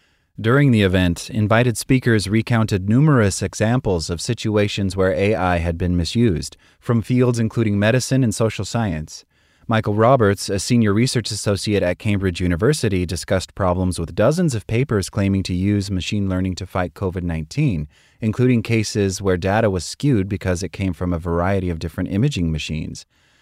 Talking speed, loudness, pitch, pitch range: 160 wpm, -19 LUFS, 100 Hz, 90-115 Hz